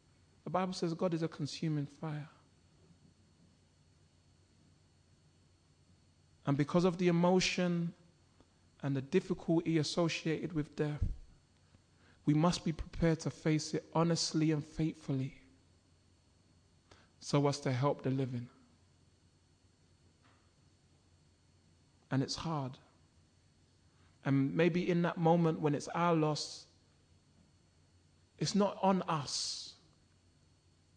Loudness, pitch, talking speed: -34 LUFS, 120 Hz, 100 wpm